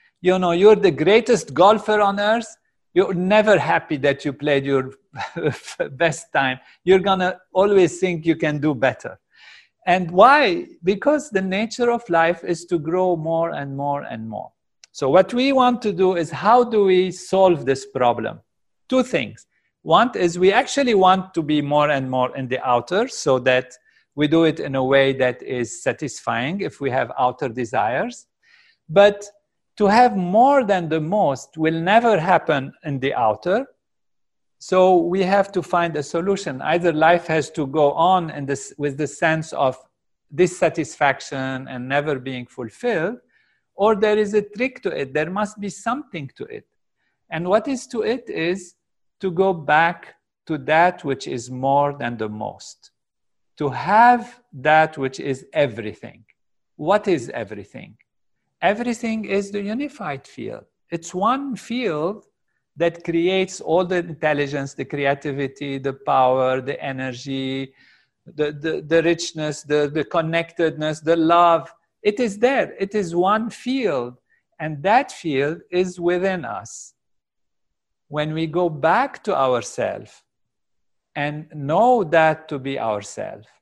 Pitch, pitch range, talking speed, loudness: 165 Hz, 145-195 Hz, 155 wpm, -20 LUFS